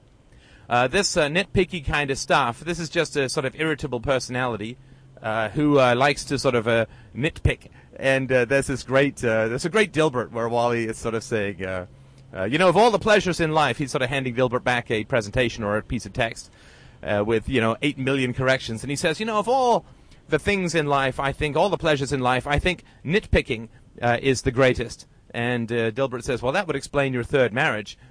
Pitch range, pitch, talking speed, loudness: 120-150 Hz, 135 Hz, 225 wpm, -23 LUFS